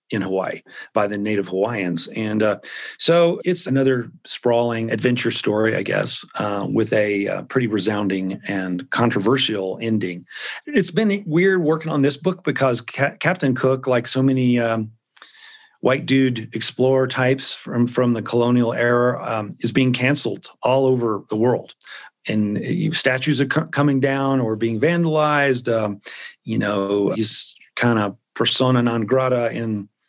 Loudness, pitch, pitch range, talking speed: -20 LUFS, 125 Hz, 110-140 Hz, 150 wpm